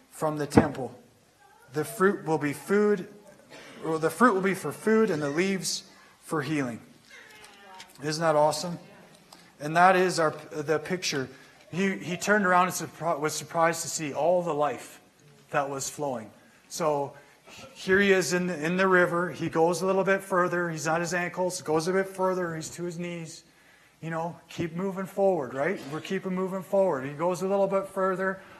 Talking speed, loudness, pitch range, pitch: 185 wpm, -27 LUFS, 155-190 Hz, 175 Hz